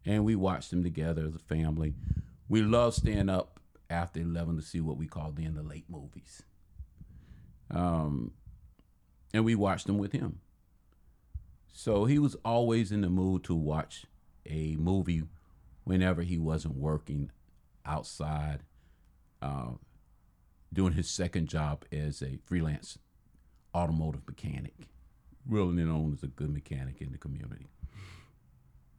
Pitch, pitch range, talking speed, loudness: 80 Hz, 75-90 Hz, 130 wpm, -33 LUFS